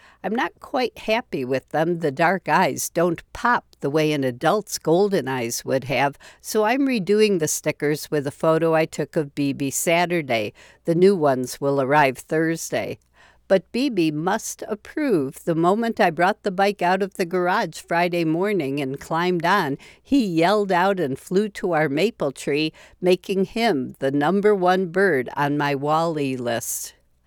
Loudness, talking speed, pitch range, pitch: -22 LUFS, 165 wpm, 145-195 Hz, 165 Hz